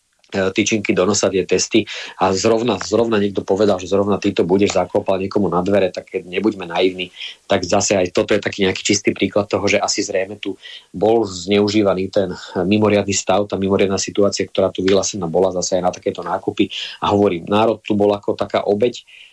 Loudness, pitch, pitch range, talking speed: -18 LUFS, 100 Hz, 95-105 Hz, 185 wpm